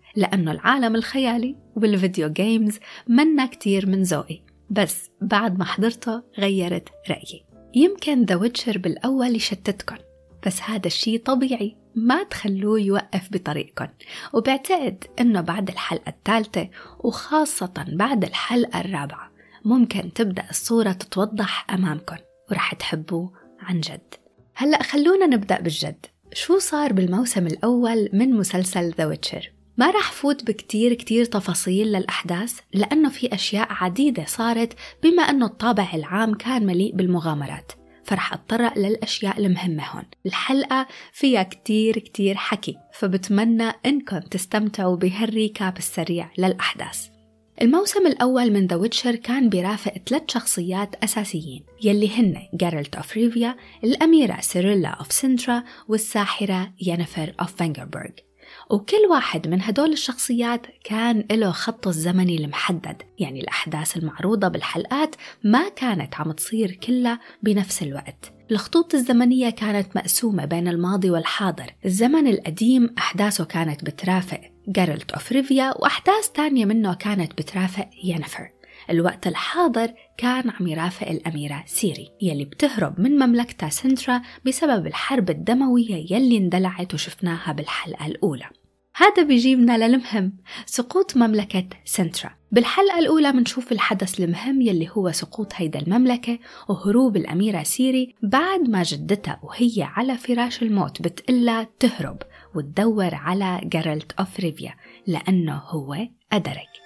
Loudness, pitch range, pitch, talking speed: -22 LUFS, 180-240 Hz, 210 Hz, 120 wpm